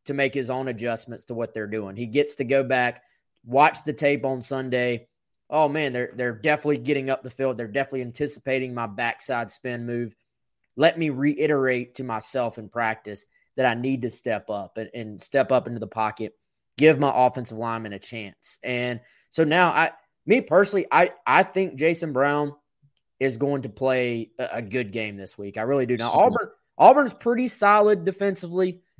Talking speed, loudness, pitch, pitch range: 190 wpm, -23 LUFS, 130 Hz, 115-145 Hz